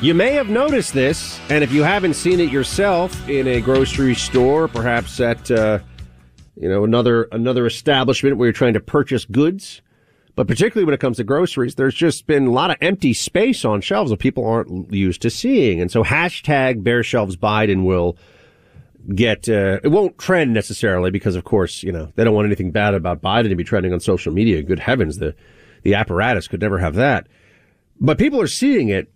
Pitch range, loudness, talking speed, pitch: 100-135 Hz, -17 LUFS, 200 wpm, 120 Hz